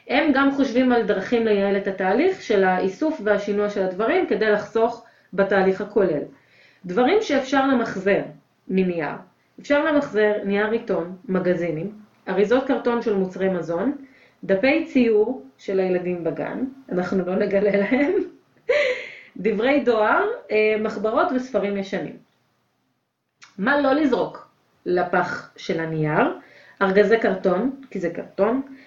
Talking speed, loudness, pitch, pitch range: 115 wpm, -22 LUFS, 215 Hz, 190-270 Hz